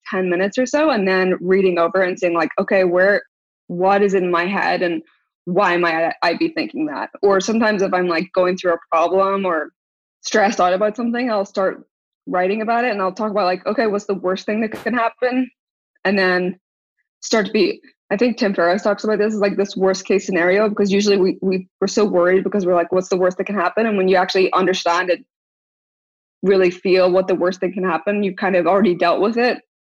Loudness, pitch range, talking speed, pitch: -18 LUFS, 180-210 Hz, 225 wpm, 190 Hz